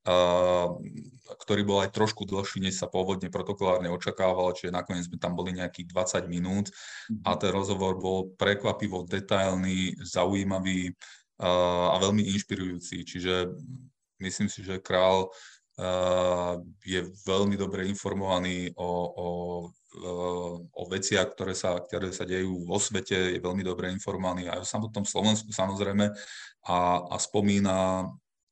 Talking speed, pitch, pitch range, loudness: 125 wpm, 95 Hz, 90-100 Hz, -29 LUFS